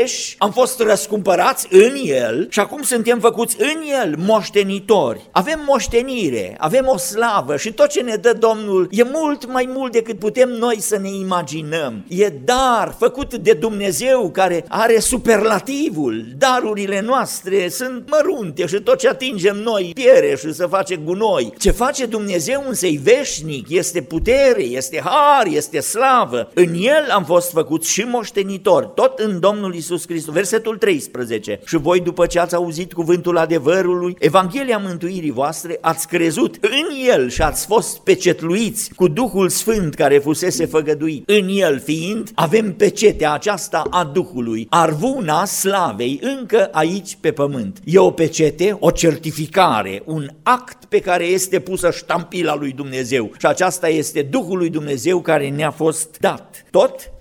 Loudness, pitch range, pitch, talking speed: -17 LUFS, 170-240 Hz, 195 Hz, 150 wpm